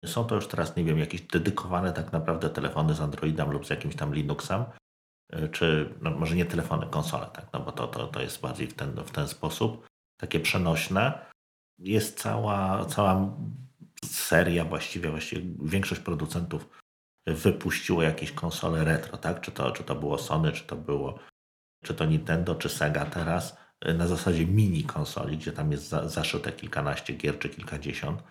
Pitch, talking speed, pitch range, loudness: 85 Hz, 165 wpm, 75-95 Hz, -29 LUFS